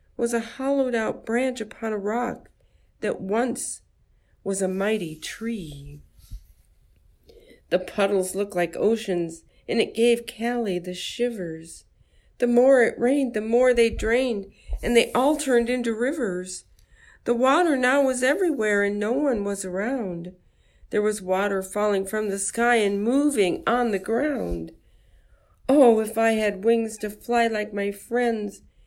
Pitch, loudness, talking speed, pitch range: 225 Hz, -24 LUFS, 150 wpm, 200-245 Hz